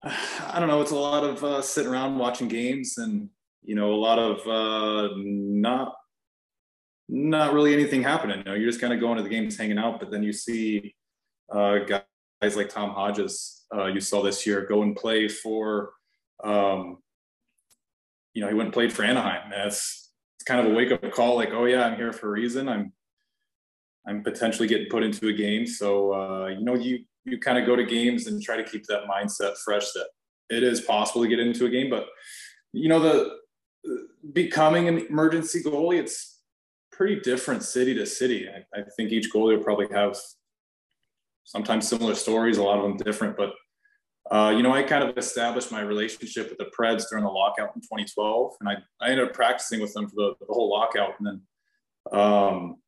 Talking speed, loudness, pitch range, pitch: 200 wpm, -25 LUFS, 105-130 Hz, 115 Hz